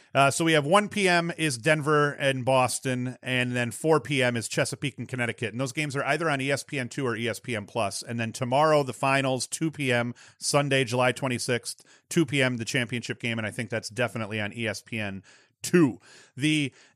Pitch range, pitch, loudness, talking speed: 120-145 Hz, 130 Hz, -26 LUFS, 180 wpm